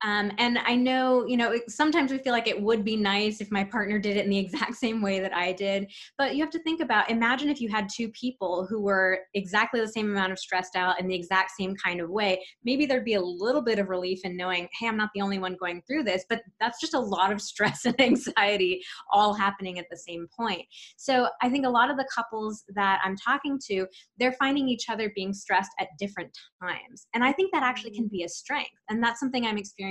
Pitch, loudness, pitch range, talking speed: 215 Hz, -27 LUFS, 190-245 Hz, 250 wpm